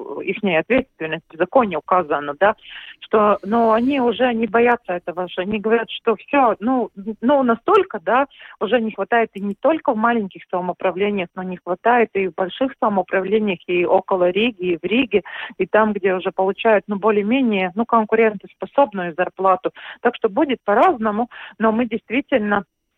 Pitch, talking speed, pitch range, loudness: 210 Hz, 160 wpm, 185-235 Hz, -19 LUFS